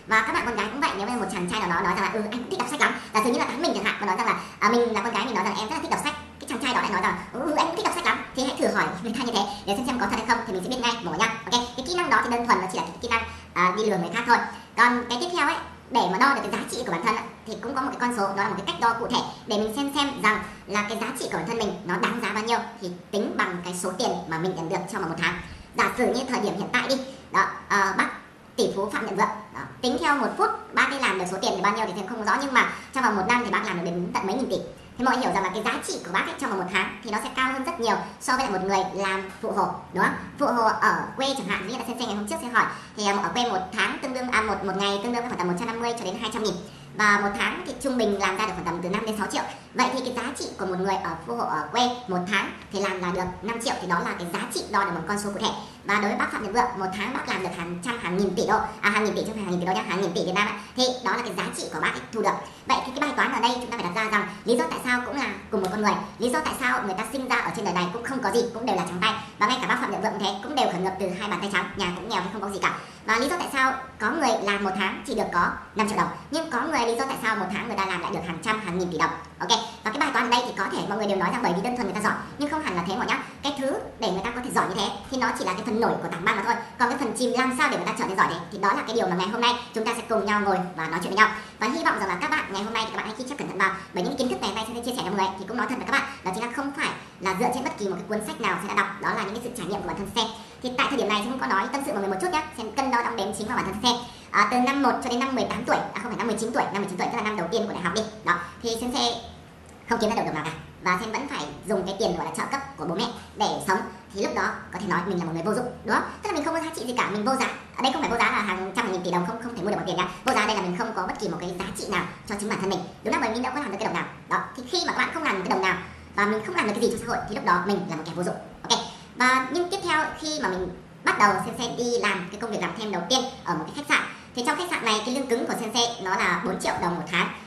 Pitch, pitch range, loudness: 215 Hz, 190-240 Hz, -26 LUFS